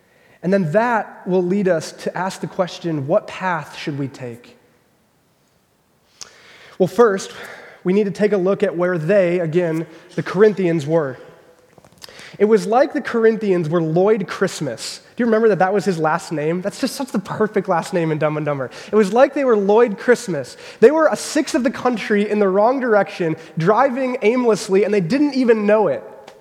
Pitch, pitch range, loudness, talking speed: 200 Hz, 175-225 Hz, -18 LUFS, 190 wpm